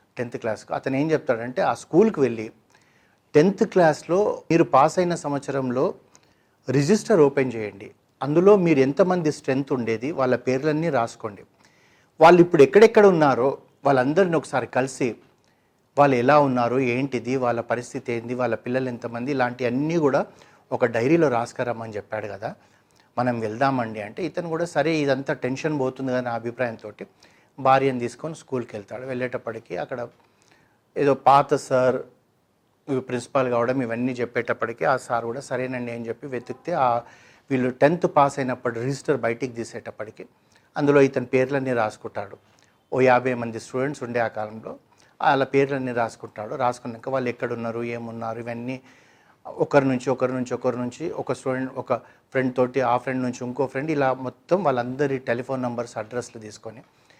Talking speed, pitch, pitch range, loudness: 135 wpm, 130 Hz, 120-140 Hz, -23 LUFS